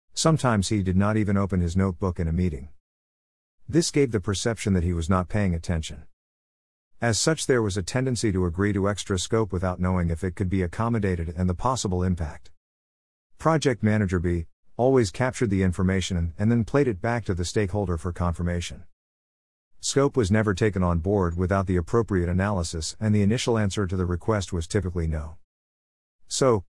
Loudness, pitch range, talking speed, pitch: -25 LUFS, 85-110 Hz, 180 wpm, 95 Hz